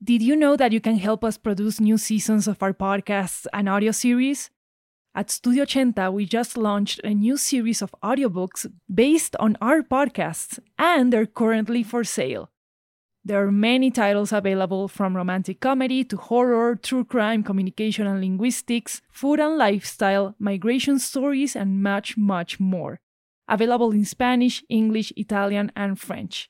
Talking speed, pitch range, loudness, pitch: 155 wpm, 200-245 Hz, -22 LUFS, 220 Hz